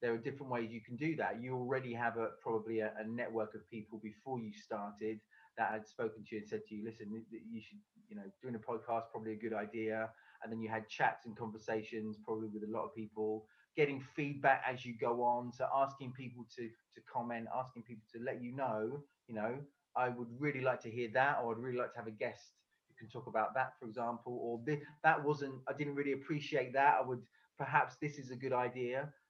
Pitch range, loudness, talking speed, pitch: 110-130 Hz, -39 LUFS, 230 wpm, 120 Hz